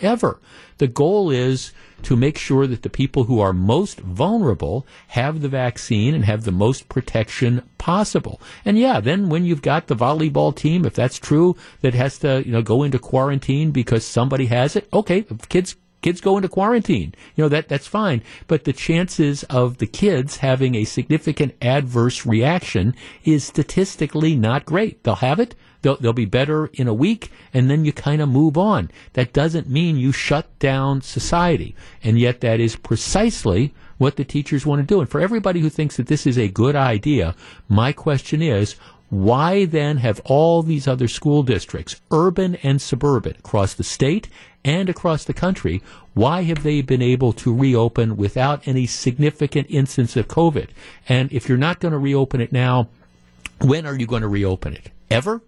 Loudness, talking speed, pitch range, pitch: -19 LUFS, 185 wpm, 120-155 Hz, 135 Hz